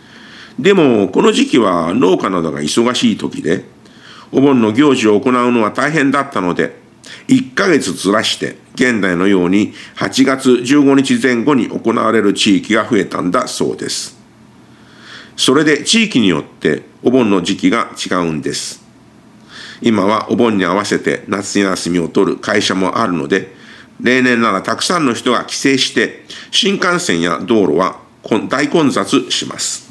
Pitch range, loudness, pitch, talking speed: 100-145 Hz, -14 LUFS, 125 Hz, 275 characters per minute